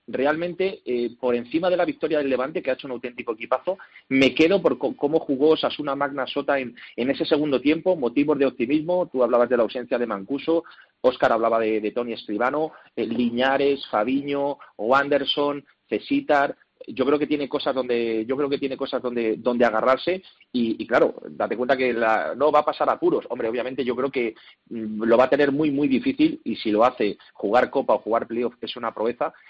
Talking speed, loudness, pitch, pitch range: 205 wpm, -23 LUFS, 140 Hz, 125-150 Hz